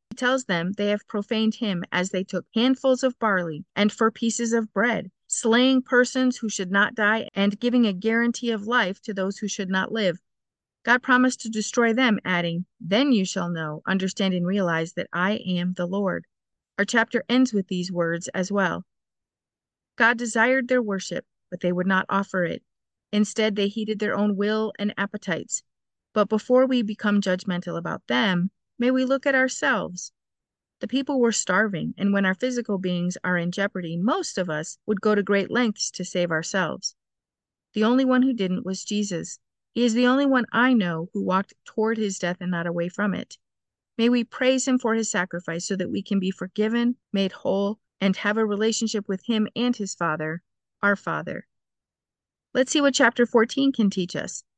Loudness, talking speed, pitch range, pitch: -24 LUFS, 190 wpm, 185-235 Hz, 205 Hz